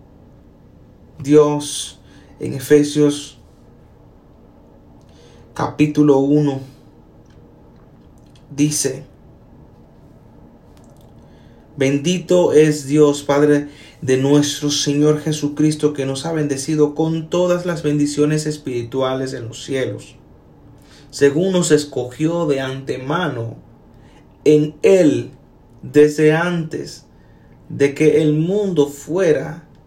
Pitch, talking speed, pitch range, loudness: 145 Hz, 80 wpm, 135-150 Hz, -17 LUFS